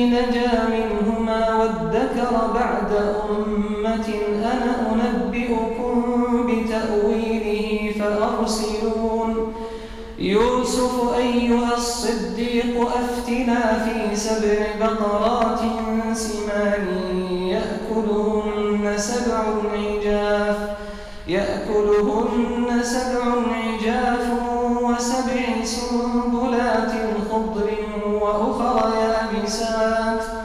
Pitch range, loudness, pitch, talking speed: 215-240 Hz, -21 LUFS, 225 Hz, 55 wpm